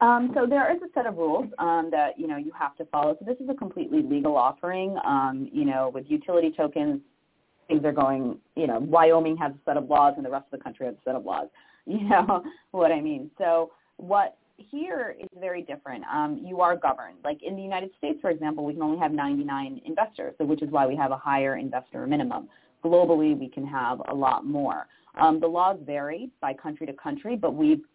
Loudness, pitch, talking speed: -26 LUFS, 165 Hz, 230 wpm